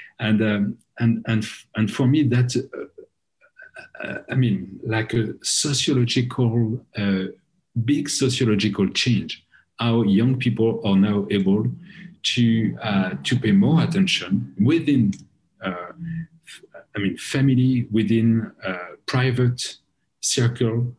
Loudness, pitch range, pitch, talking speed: -21 LUFS, 110-145 Hz, 120 Hz, 110 wpm